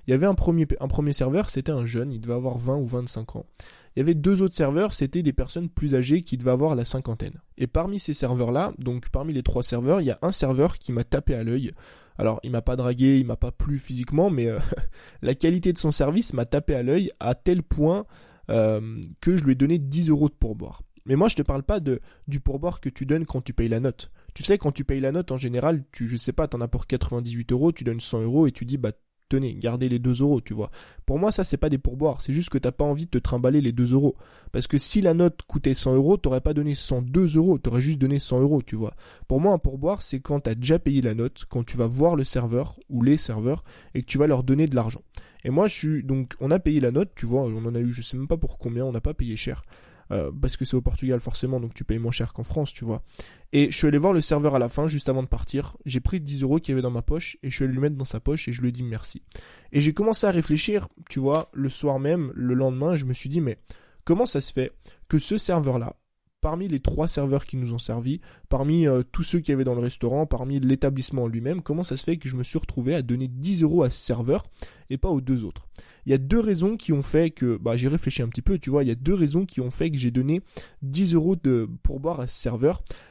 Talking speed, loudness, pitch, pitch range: 280 wpm, -25 LUFS, 135 Hz, 125-155 Hz